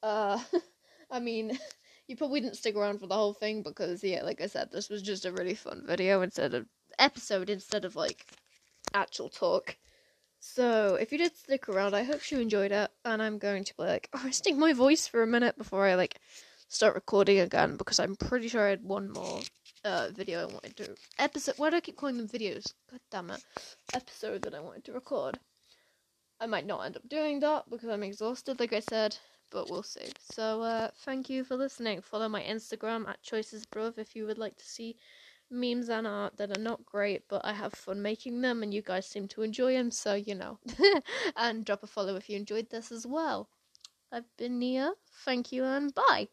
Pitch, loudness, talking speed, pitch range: 225 Hz, -32 LUFS, 215 wpm, 205-260 Hz